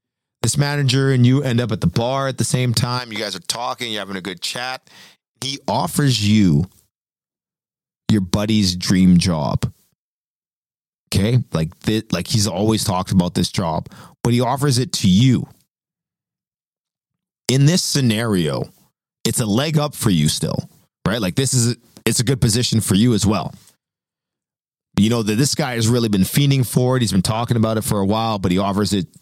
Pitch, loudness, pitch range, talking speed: 115 Hz, -18 LUFS, 105-130 Hz, 185 wpm